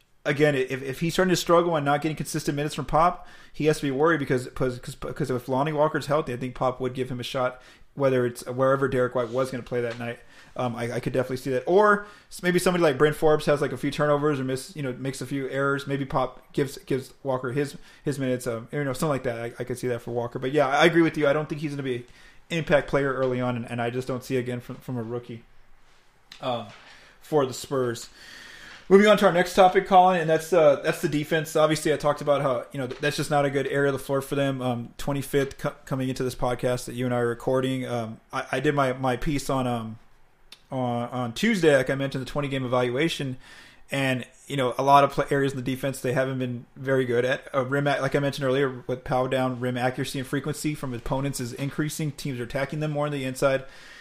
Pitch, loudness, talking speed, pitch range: 135 Hz, -25 LUFS, 255 wpm, 125-150 Hz